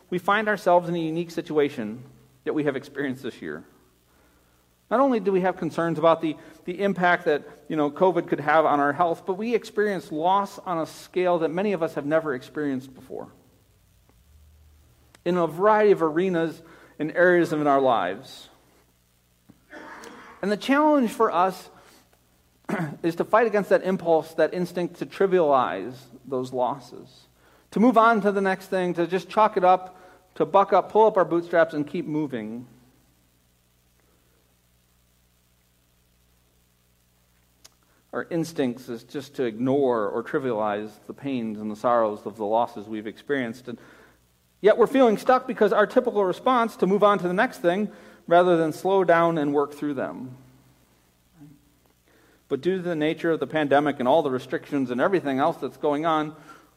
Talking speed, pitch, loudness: 165 wpm, 155 Hz, -23 LUFS